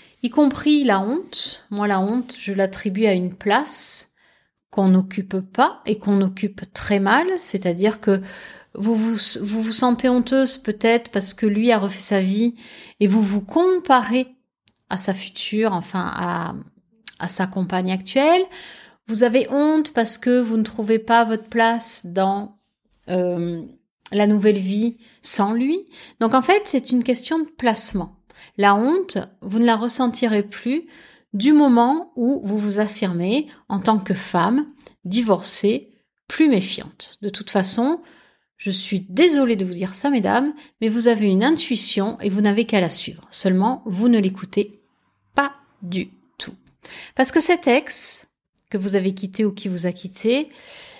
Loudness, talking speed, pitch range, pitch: -20 LUFS, 160 wpm, 200-255 Hz, 220 Hz